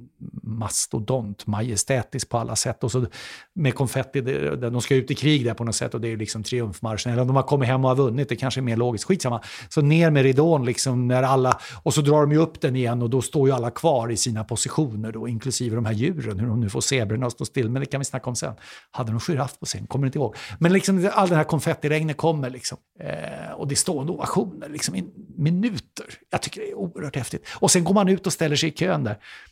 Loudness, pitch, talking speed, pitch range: -23 LUFS, 130 Hz, 250 wpm, 120-150 Hz